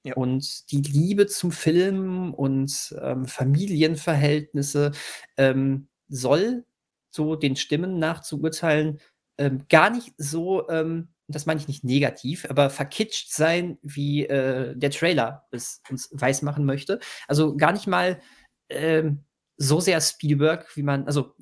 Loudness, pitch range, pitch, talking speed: -24 LUFS, 140-165 Hz, 150 Hz, 140 wpm